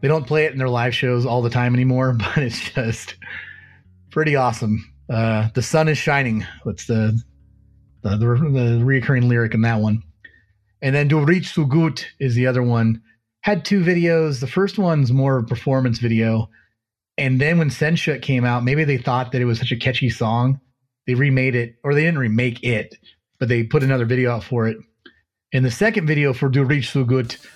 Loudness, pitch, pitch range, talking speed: -19 LUFS, 125 Hz, 115-140 Hz, 200 wpm